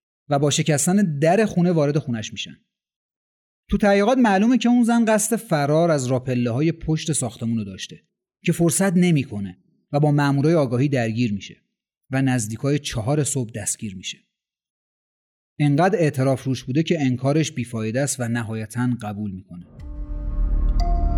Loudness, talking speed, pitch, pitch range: -21 LUFS, 140 wpm, 140 Hz, 115-160 Hz